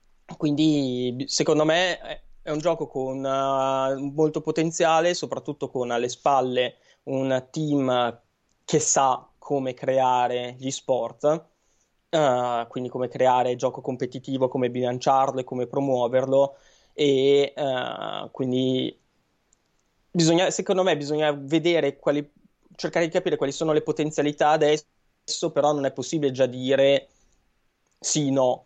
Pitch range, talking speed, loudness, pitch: 130-150 Hz, 125 wpm, -24 LUFS, 135 Hz